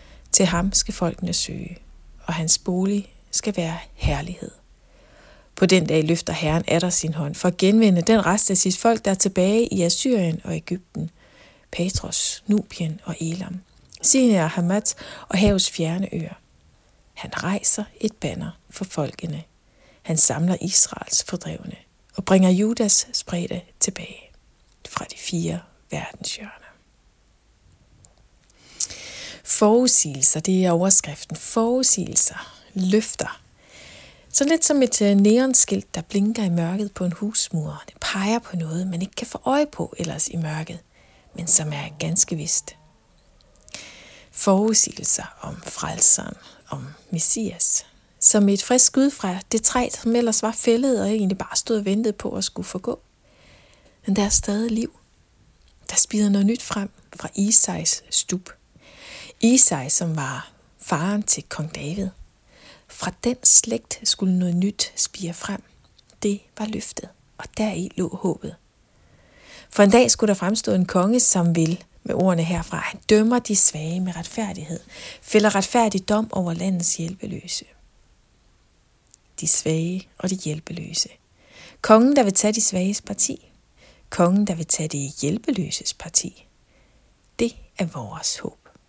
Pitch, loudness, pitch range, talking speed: 190 Hz, -18 LUFS, 170-215 Hz, 140 wpm